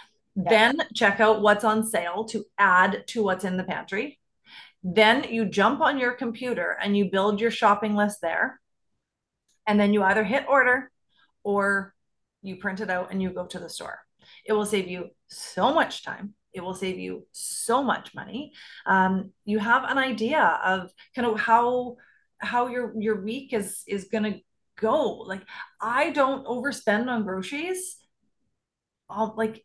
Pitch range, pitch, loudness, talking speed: 195-240 Hz, 215 Hz, -24 LUFS, 165 wpm